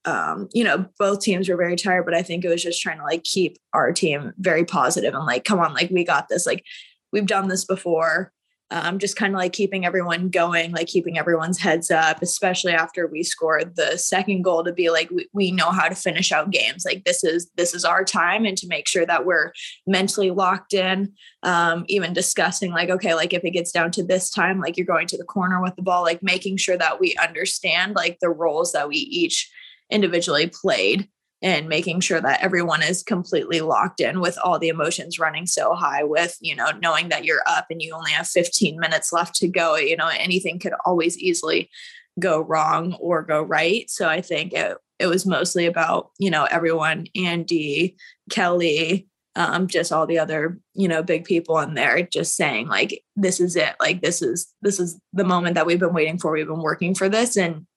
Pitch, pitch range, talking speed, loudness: 180 Hz, 170-190 Hz, 215 wpm, -21 LUFS